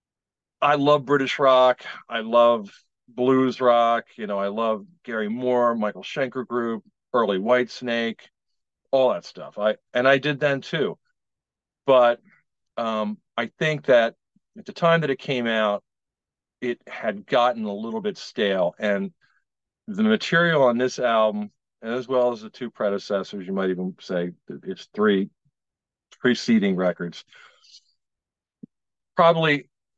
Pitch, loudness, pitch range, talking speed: 125 Hz, -23 LUFS, 110-145 Hz, 135 wpm